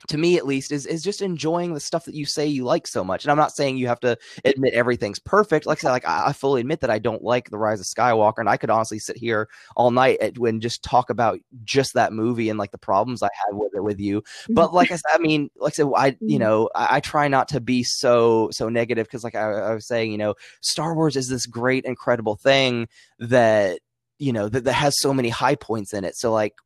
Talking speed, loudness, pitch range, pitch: 265 wpm, -21 LUFS, 115-145 Hz, 125 Hz